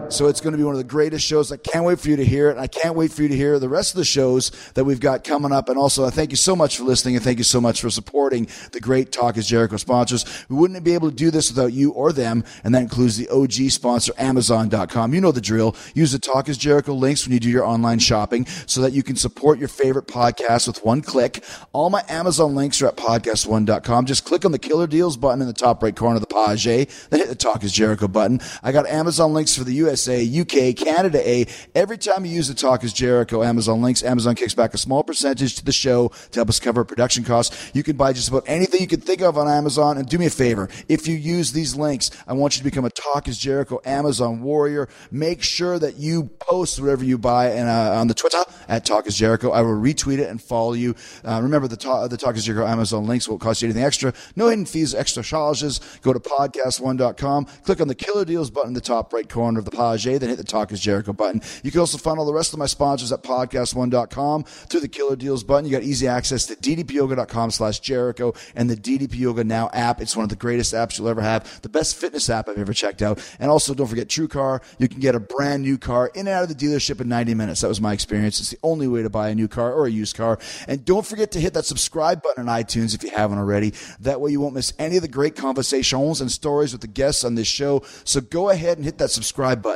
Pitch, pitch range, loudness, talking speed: 130 Hz, 115-145 Hz, -20 LUFS, 265 wpm